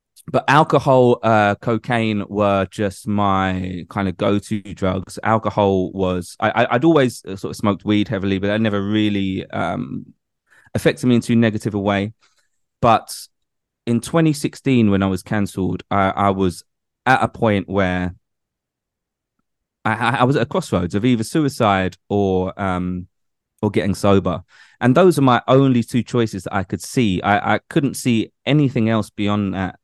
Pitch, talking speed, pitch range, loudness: 105 Hz, 165 wpm, 95-120 Hz, -18 LUFS